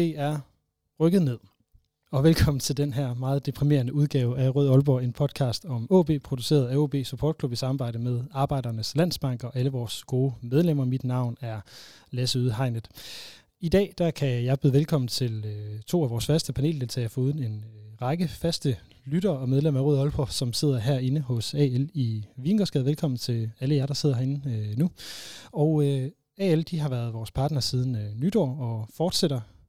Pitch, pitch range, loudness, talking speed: 135 Hz, 120-150 Hz, -26 LUFS, 175 wpm